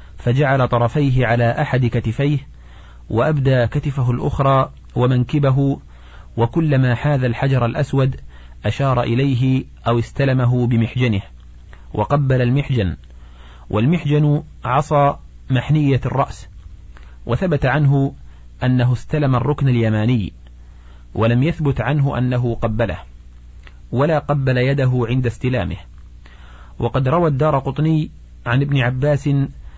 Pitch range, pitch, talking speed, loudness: 90-140 Hz, 125 Hz, 95 wpm, -18 LUFS